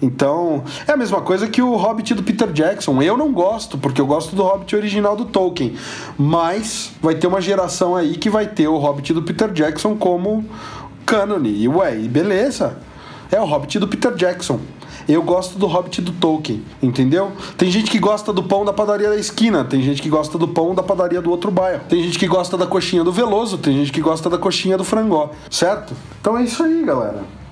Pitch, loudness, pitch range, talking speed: 185 Hz, -18 LUFS, 165-210 Hz, 210 wpm